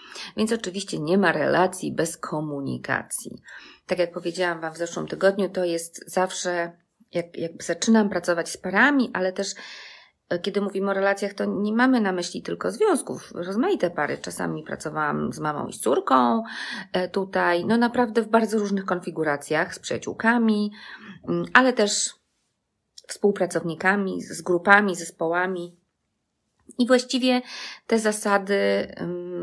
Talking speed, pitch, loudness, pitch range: 135 wpm, 185 Hz, -24 LUFS, 170-210 Hz